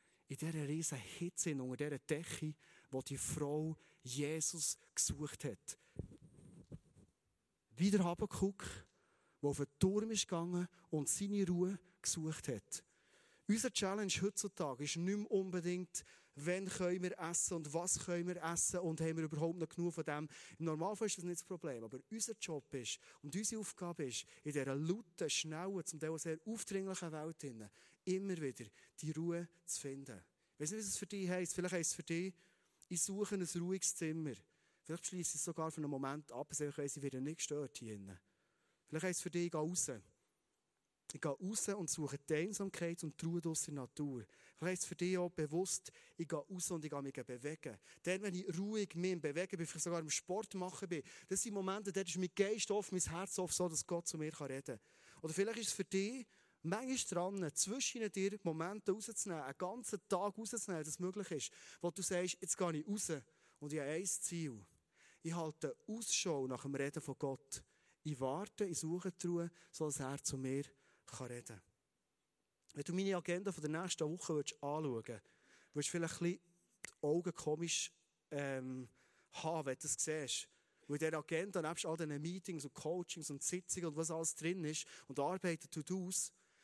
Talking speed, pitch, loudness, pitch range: 190 wpm, 170 Hz, -42 LUFS, 150-185 Hz